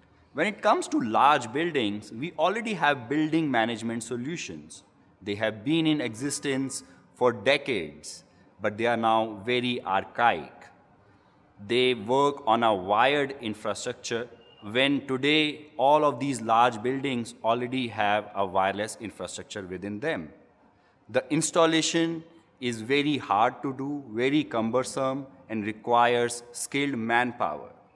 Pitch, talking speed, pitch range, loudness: 125 Hz, 125 wpm, 110-140 Hz, -26 LUFS